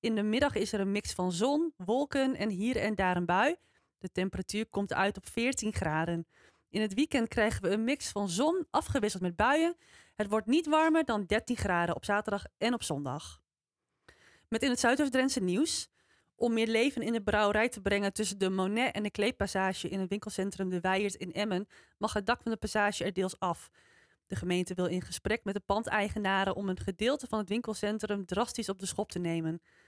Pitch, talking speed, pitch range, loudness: 210 Hz, 205 wpm, 190-235 Hz, -31 LUFS